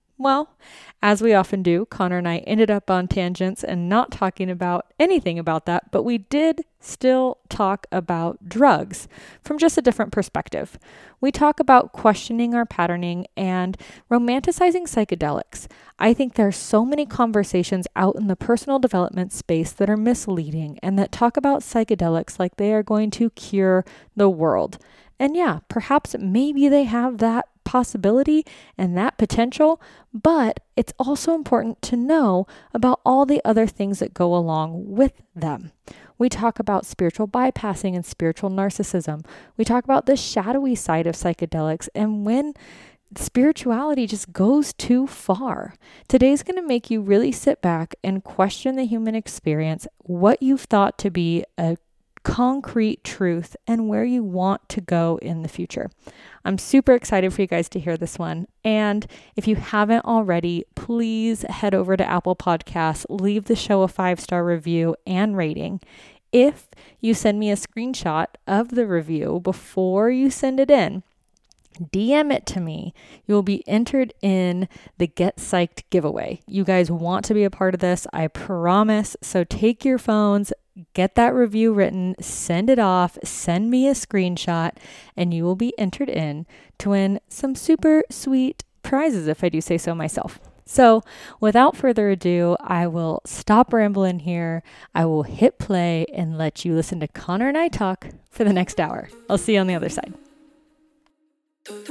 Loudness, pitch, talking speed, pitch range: -21 LUFS, 205 Hz, 165 wpm, 180-245 Hz